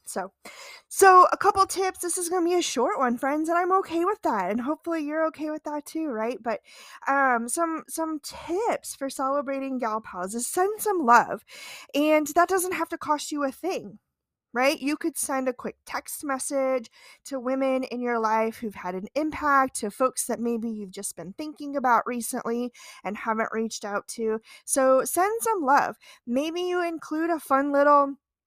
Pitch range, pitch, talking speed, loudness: 240-330 Hz, 275 Hz, 190 wpm, -25 LUFS